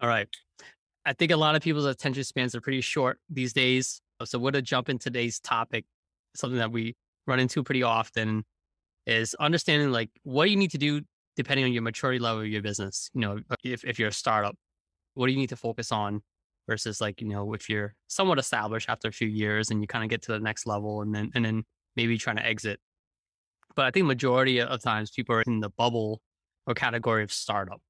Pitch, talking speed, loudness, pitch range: 115 Hz, 225 wpm, -28 LUFS, 105-130 Hz